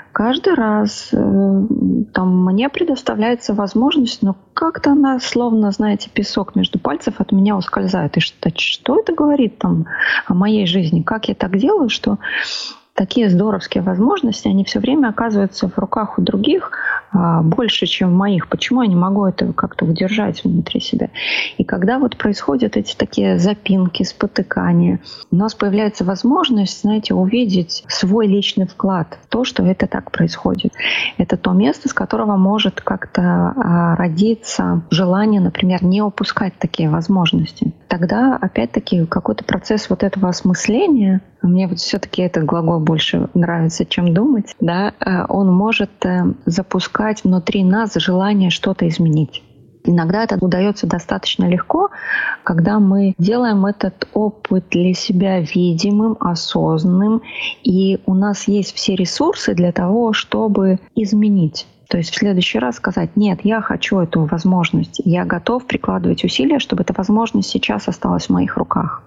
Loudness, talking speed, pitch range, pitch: -16 LUFS, 140 wpm, 185-225 Hz, 200 Hz